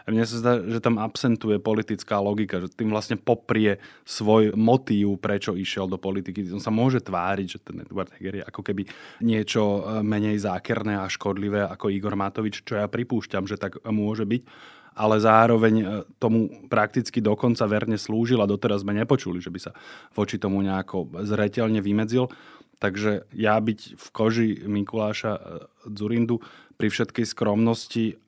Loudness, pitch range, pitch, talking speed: -25 LUFS, 100-115 Hz, 105 Hz, 155 wpm